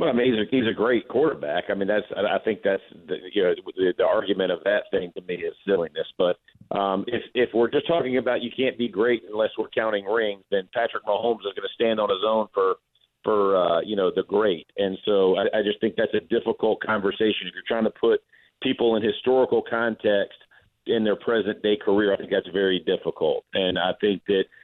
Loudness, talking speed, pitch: -24 LUFS, 230 wpm, 130 Hz